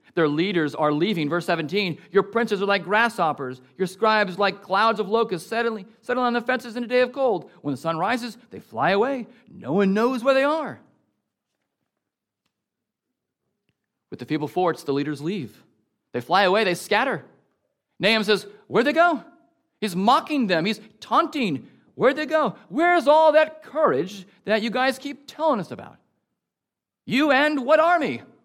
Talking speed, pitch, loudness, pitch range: 170 wpm, 220 Hz, -22 LUFS, 185-265 Hz